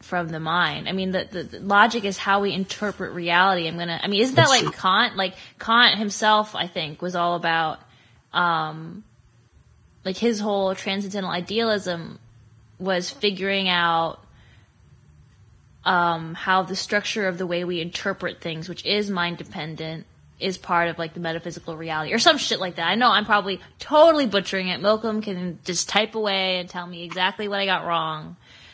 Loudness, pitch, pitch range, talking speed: -22 LUFS, 185 Hz, 170-200 Hz, 180 wpm